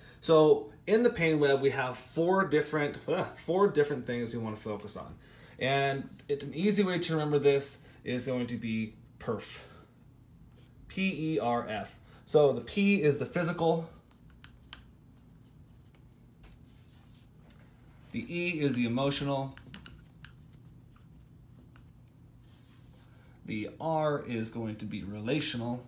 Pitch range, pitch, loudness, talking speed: 125-155 Hz, 140 Hz, -30 LUFS, 125 wpm